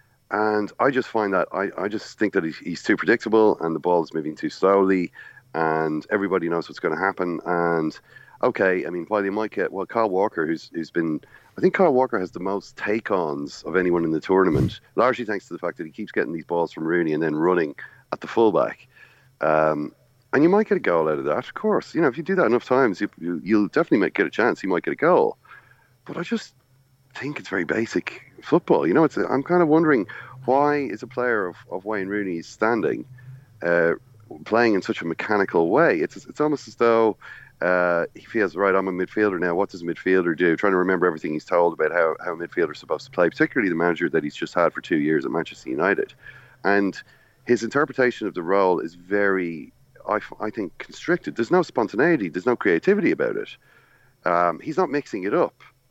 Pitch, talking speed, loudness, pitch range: 105 Hz, 230 wpm, -23 LUFS, 85-130 Hz